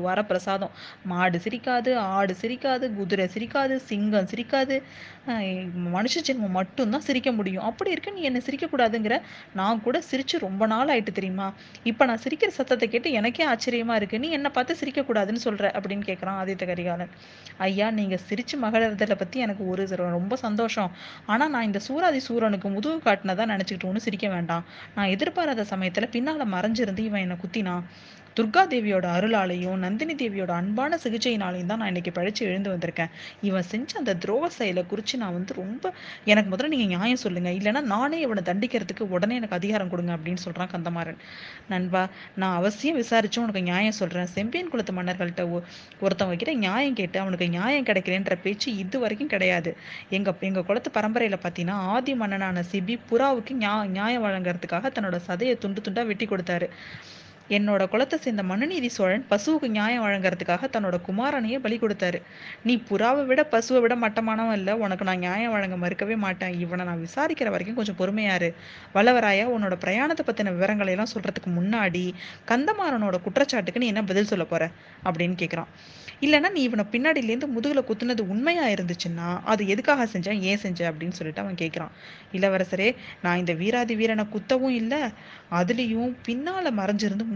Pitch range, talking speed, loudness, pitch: 185-240 Hz, 155 wpm, -26 LUFS, 210 Hz